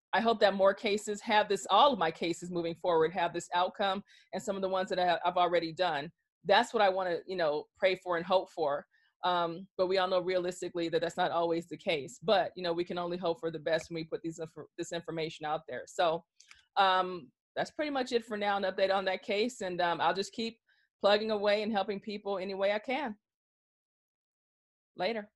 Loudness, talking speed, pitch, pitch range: -32 LUFS, 225 wpm, 185 Hz, 170-205 Hz